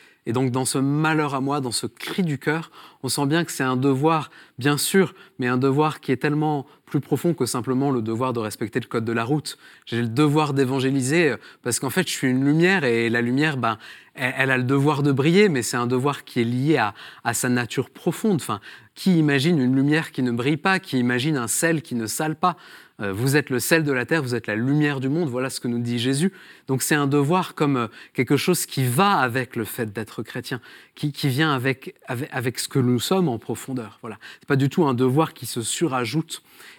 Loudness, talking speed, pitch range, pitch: -22 LUFS, 240 wpm, 125-155 Hz, 135 Hz